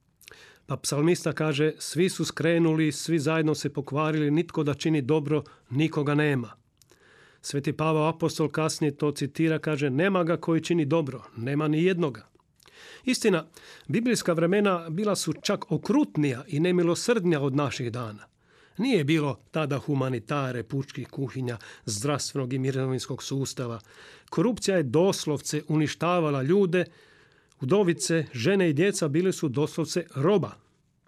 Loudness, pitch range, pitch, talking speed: -26 LUFS, 140-170 Hz, 155 Hz, 125 wpm